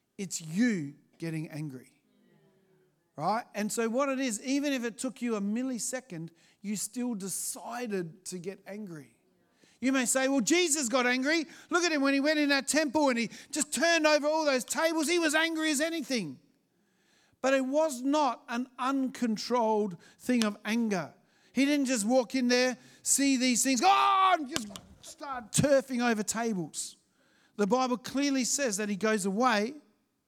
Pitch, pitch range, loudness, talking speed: 250 Hz, 210-280 Hz, -29 LUFS, 170 wpm